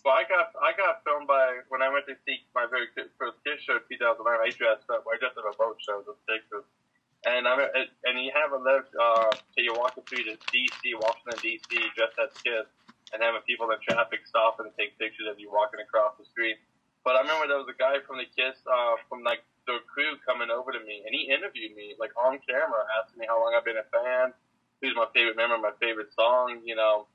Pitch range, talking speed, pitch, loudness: 110-135 Hz, 245 wpm, 125 Hz, -27 LUFS